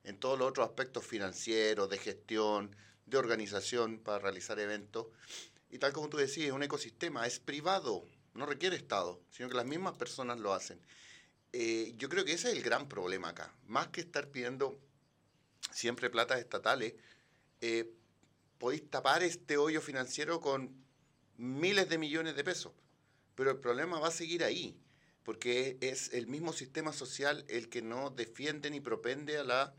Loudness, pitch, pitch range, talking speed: -37 LUFS, 130 Hz, 115-150 Hz, 165 wpm